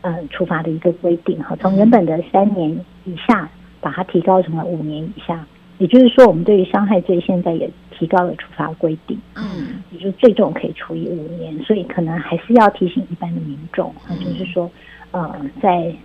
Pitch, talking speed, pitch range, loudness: 180 Hz, 295 characters per minute, 170-195 Hz, -17 LUFS